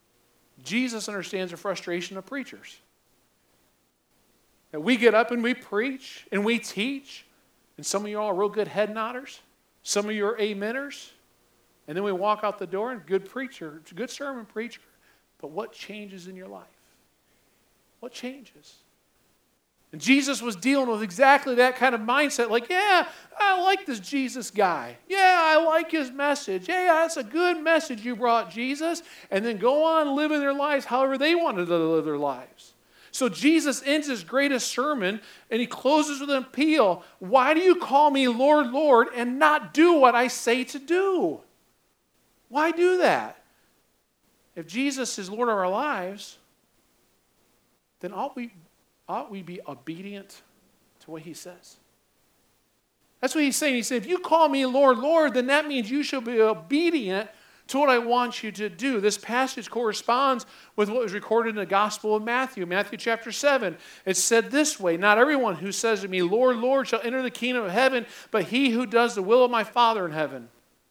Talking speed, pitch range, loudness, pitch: 180 wpm, 205-280 Hz, -24 LUFS, 245 Hz